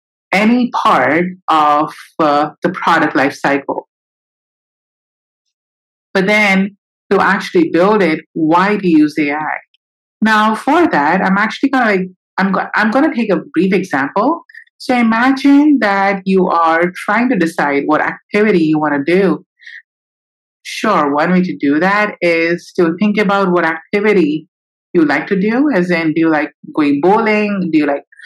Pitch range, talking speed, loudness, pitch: 160-215 Hz, 160 wpm, -13 LUFS, 190 Hz